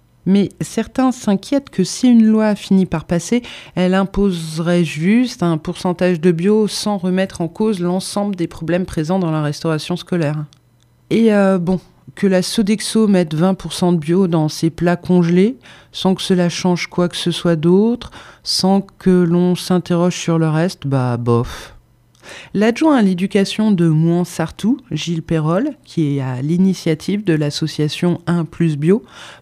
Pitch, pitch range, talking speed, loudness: 180 Hz, 165-195 Hz, 160 wpm, -17 LUFS